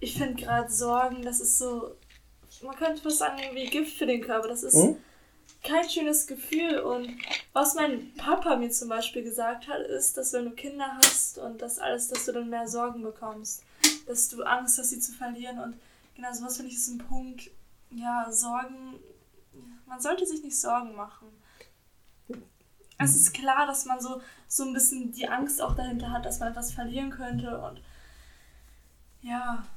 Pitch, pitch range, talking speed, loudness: 245 Hz, 235-270 Hz, 180 wpm, -27 LUFS